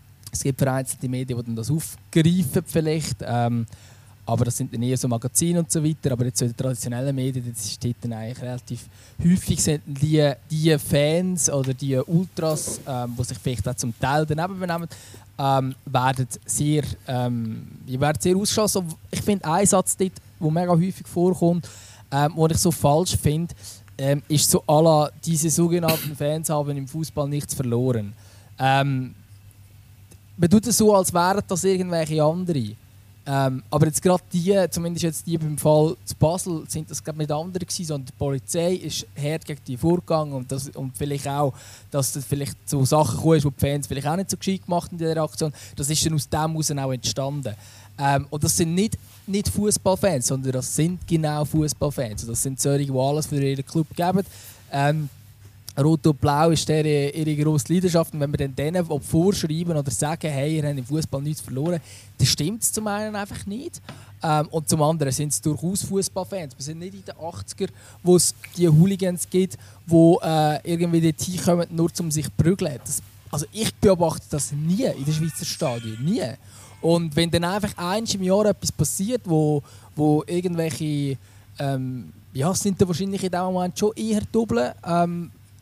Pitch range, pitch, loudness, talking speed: 130-170 Hz, 150 Hz, -23 LUFS, 185 wpm